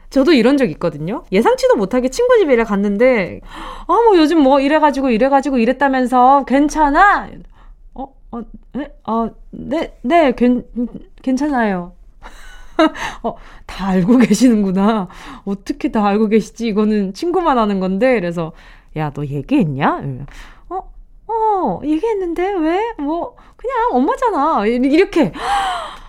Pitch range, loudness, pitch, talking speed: 215-325 Hz, -15 LUFS, 260 Hz, 260 characters per minute